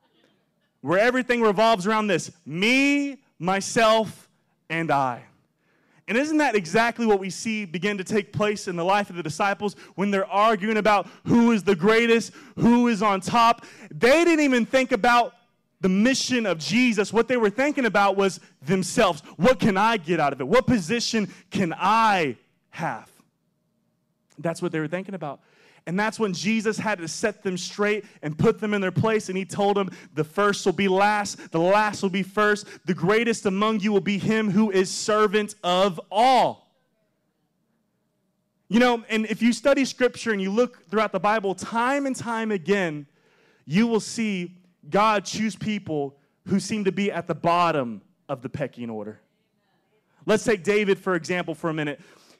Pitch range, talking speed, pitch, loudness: 185-220 Hz, 180 wpm, 205 Hz, -23 LUFS